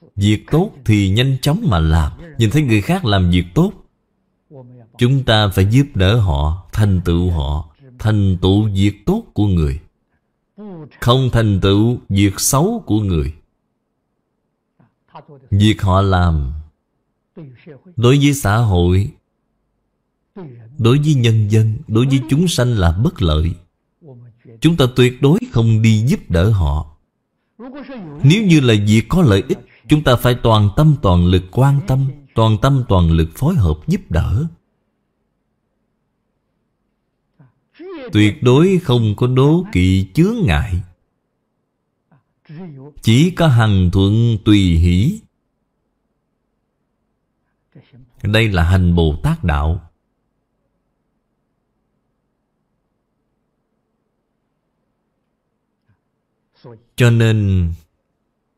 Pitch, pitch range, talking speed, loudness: 115 Hz, 95-140 Hz, 110 wpm, -15 LUFS